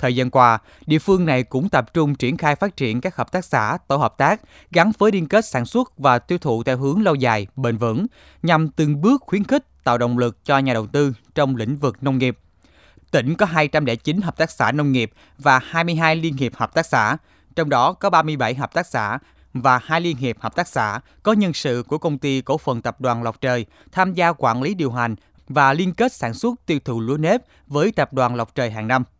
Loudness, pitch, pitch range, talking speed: -20 LUFS, 140 Hz, 125-165 Hz, 235 wpm